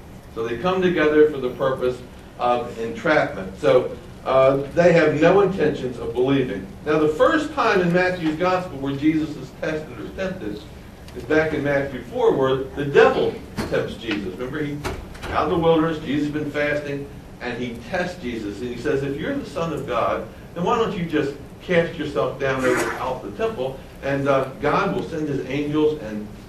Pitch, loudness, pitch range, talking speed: 145 Hz, -22 LUFS, 125-155 Hz, 190 wpm